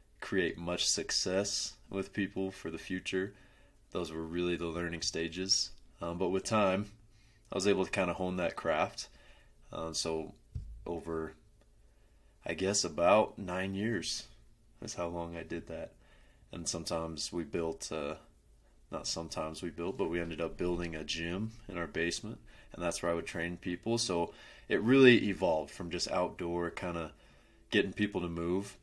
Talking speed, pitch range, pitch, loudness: 165 wpm, 85-100 Hz, 90 Hz, -34 LUFS